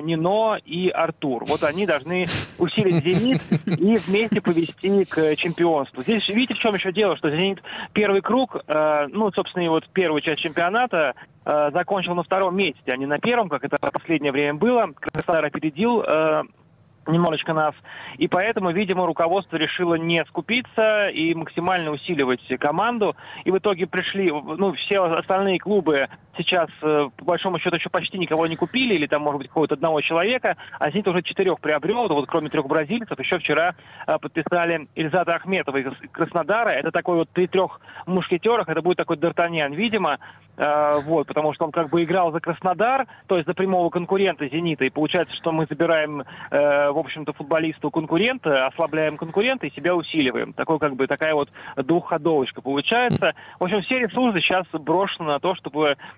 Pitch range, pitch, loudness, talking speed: 155-190 Hz, 170 Hz, -22 LUFS, 170 wpm